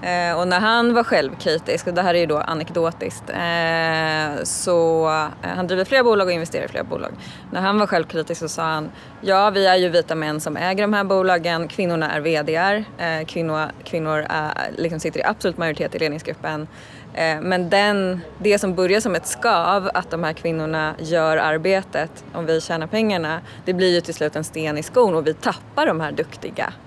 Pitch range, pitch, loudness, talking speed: 155-185 Hz, 165 Hz, -20 LUFS, 200 wpm